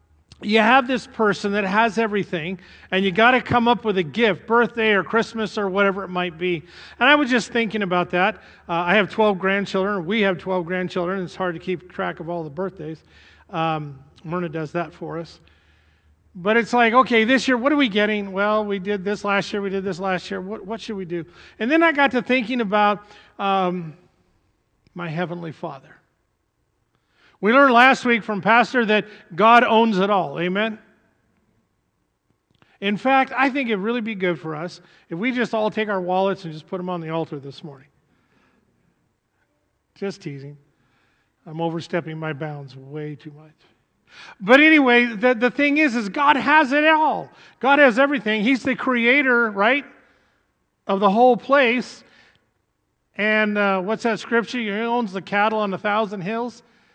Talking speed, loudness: 185 wpm, -20 LUFS